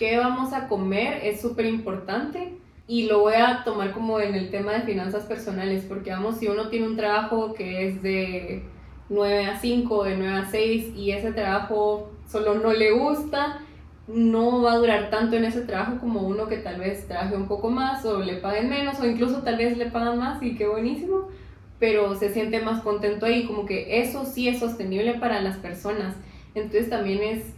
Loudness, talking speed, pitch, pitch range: -25 LUFS, 200 wpm, 220 Hz, 205-235 Hz